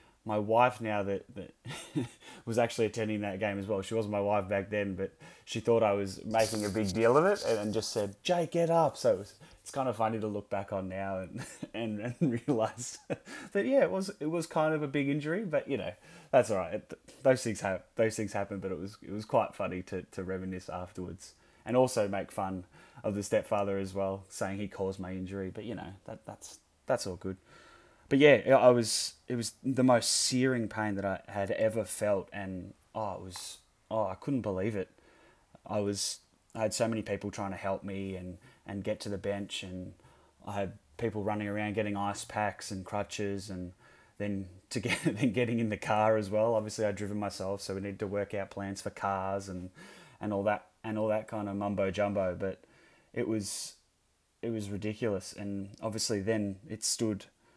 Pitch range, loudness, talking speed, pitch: 95-110 Hz, -32 LUFS, 215 wpm, 105 Hz